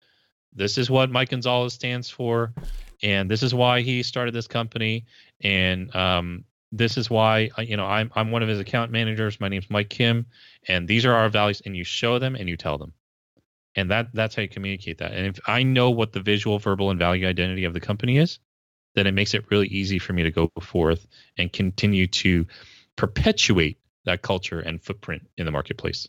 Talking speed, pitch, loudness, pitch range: 205 wpm, 105 Hz, -23 LUFS, 95-115 Hz